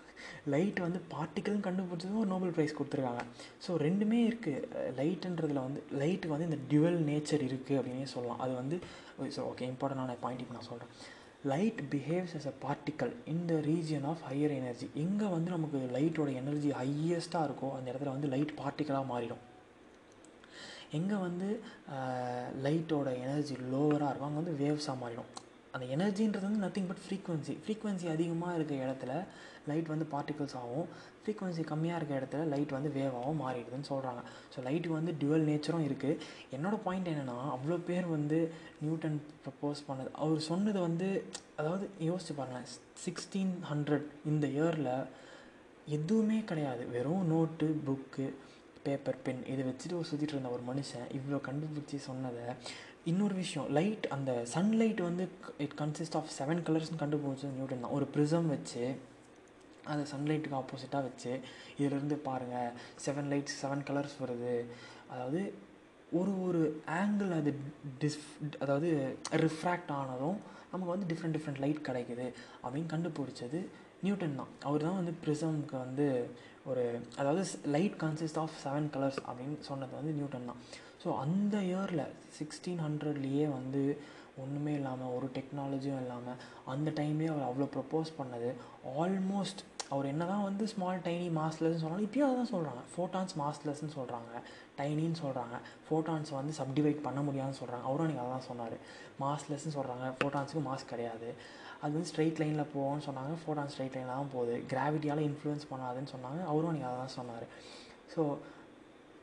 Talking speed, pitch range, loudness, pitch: 145 wpm, 135-165 Hz, -36 LUFS, 150 Hz